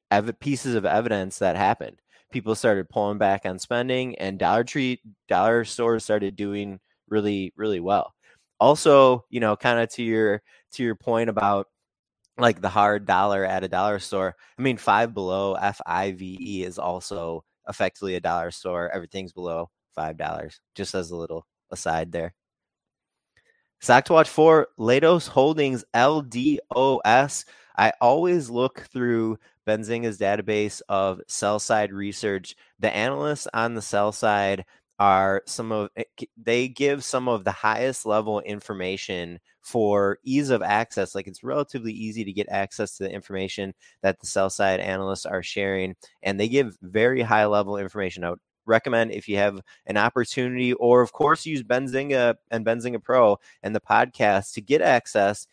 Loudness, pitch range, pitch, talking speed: -23 LUFS, 95-120 Hz, 105 Hz, 160 wpm